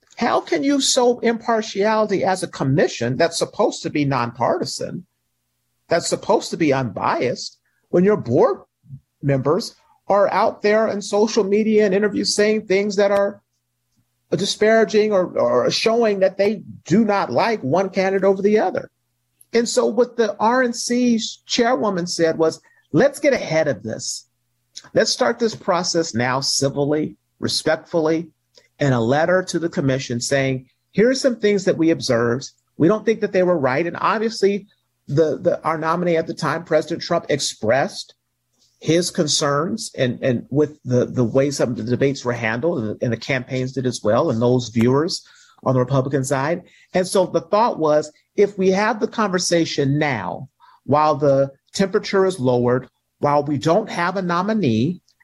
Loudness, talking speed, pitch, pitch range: -19 LUFS, 165 wpm, 165 Hz, 130-205 Hz